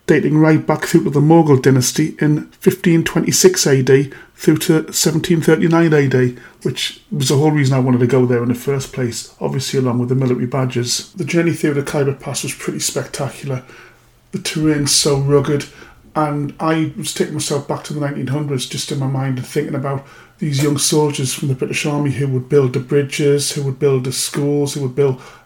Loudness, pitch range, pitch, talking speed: -16 LUFS, 135-155 Hz, 145 Hz, 200 wpm